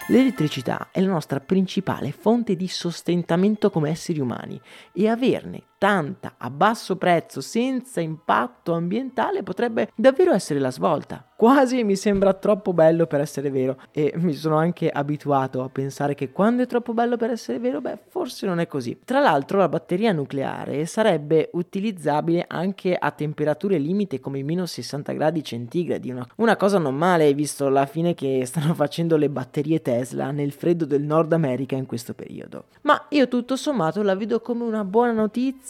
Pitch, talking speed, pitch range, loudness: 170 Hz, 170 wpm, 145-215 Hz, -22 LUFS